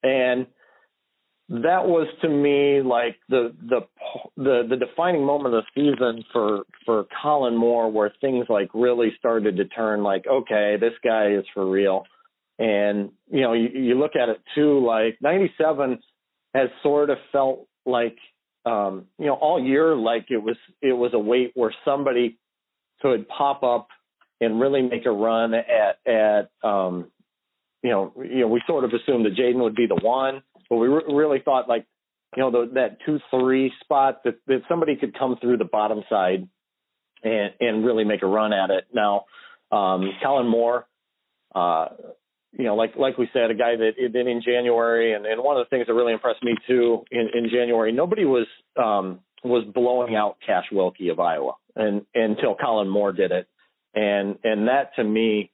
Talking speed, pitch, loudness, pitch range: 185 wpm, 120 Hz, -22 LUFS, 110-130 Hz